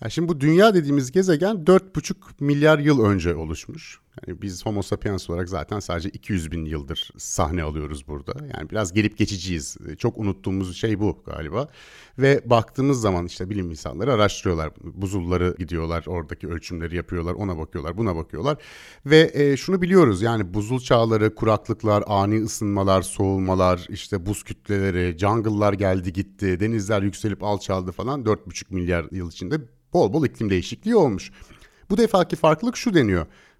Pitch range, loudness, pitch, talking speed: 90-120 Hz, -22 LUFS, 100 Hz, 145 wpm